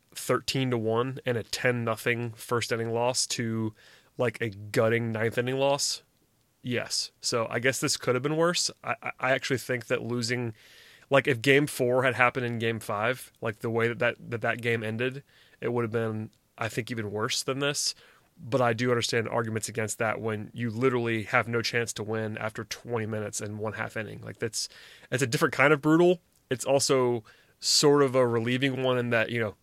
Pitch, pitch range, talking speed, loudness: 120 Hz, 115-130 Hz, 205 wpm, -28 LUFS